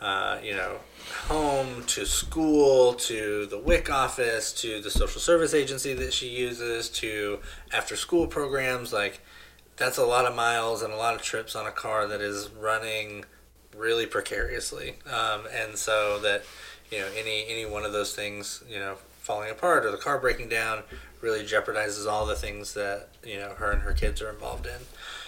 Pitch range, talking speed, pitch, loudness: 105-125 Hz, 185 wpm, 110 Hz, -28 LUFS